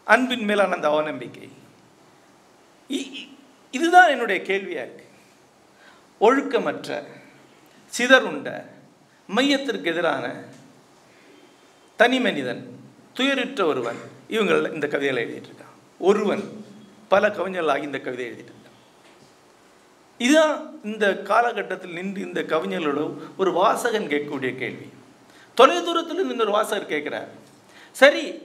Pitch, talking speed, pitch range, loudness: 235 Hz, 95 wpm, 185-280 Hz, -22 LUFS